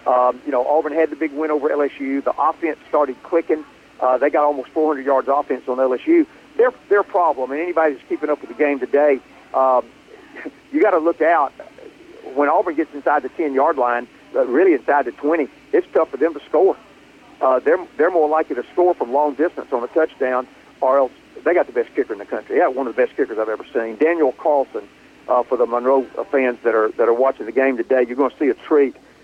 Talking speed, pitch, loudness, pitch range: 235 wpm, 150 Hz, -19 LUFS, 130-200 Hz